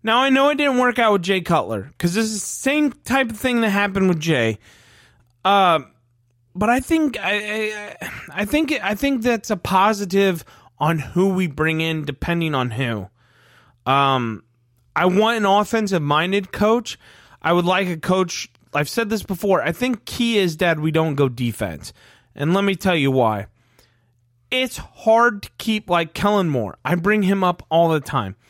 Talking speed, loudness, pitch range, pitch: 185 wpm, -20 LUFS, 130-210 Hz, 175 Hz